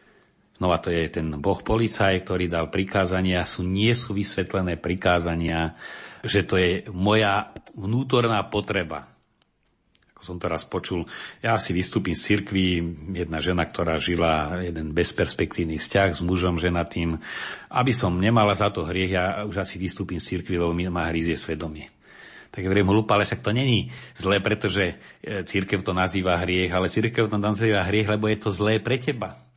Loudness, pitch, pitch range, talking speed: -24 LUFS, 95 Hz, 85-105 Hz, 170 wpm